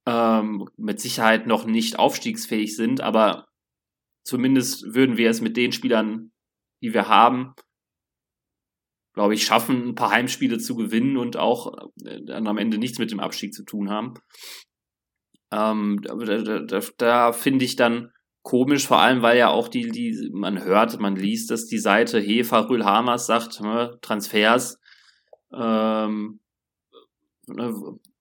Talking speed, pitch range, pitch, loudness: 145 wpm, 110-125 Hz, 115 Hz, -21 LUFS